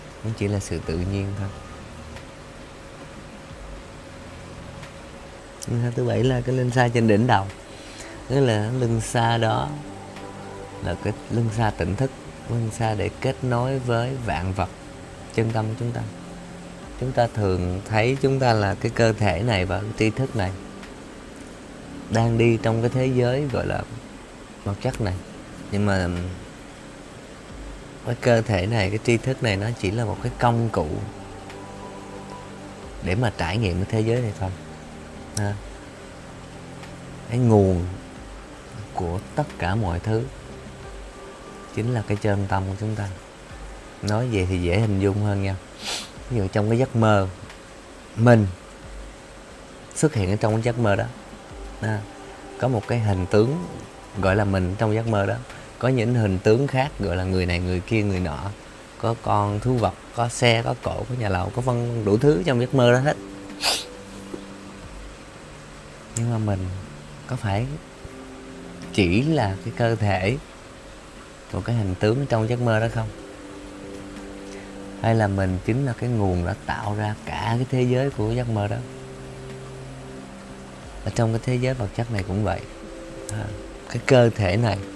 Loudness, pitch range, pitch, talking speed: -23 LUFS, 95-120 Hz, 105 Hz, 160 wpm